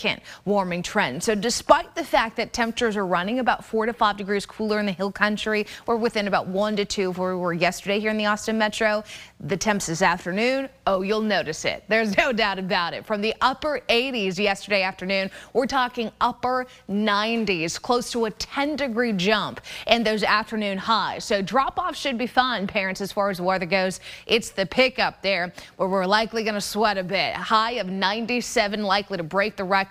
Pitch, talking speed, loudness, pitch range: 210 Hz, 205 wpm, -23 LUFS, 195-230 Hz